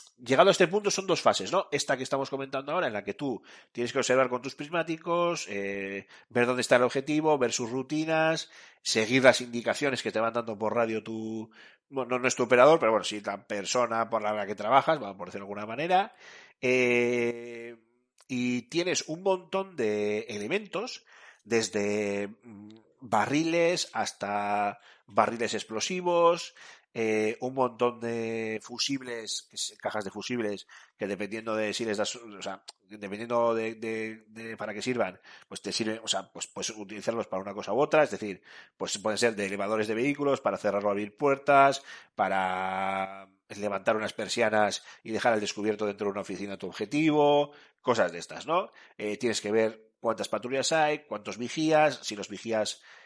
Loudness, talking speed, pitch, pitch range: -28 LUFS, 175 wpm, 115 Hz, 105-135 Hz